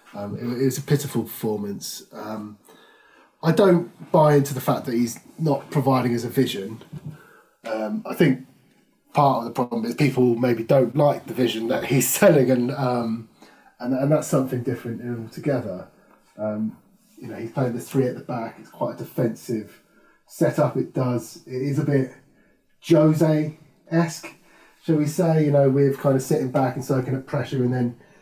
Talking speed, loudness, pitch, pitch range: 175 wpm, -22 LUFS, 130 Hz, 120-150 Hz